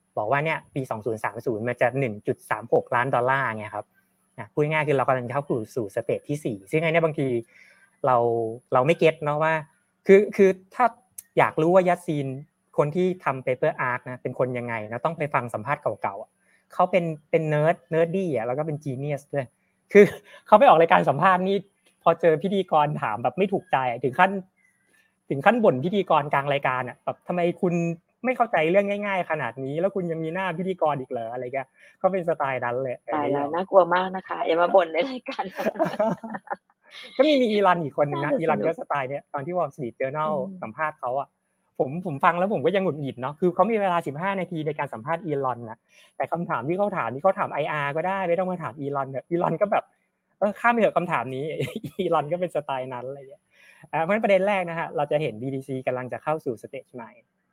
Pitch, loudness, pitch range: 160 Hz, -24 LUFS, 140-190 Hz